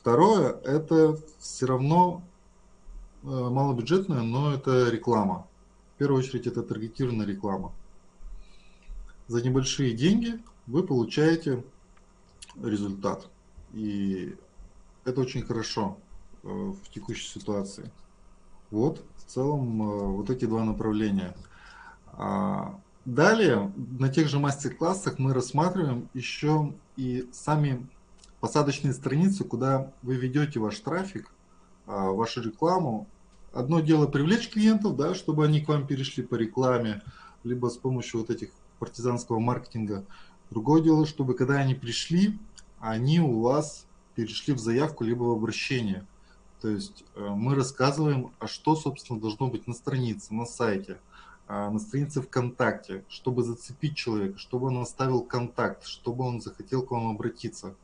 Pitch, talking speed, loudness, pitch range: 125 Hz, 120 wpm, -28 LUFS, 110-145 Hz